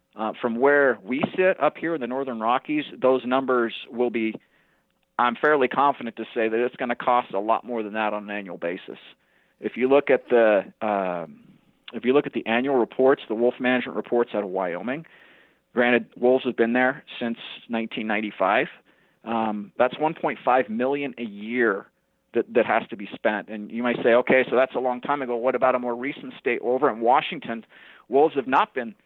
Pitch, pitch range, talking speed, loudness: 125 Hz, 115-130 Hz, 200 wpm, -24 LUFS